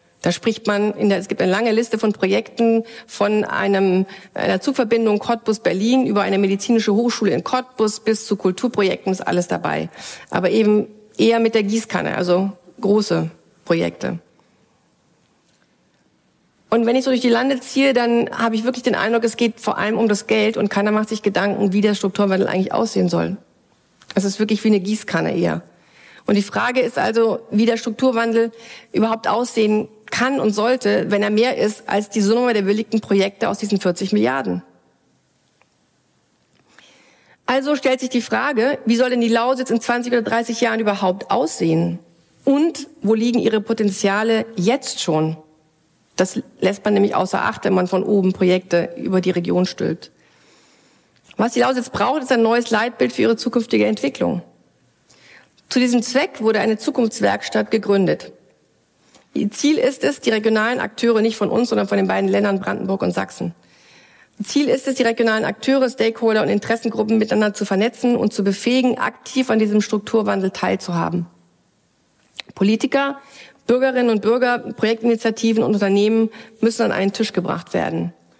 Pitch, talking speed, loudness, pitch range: 220 Hz, 160 wpm, -19 LUFS, 195-235 Hz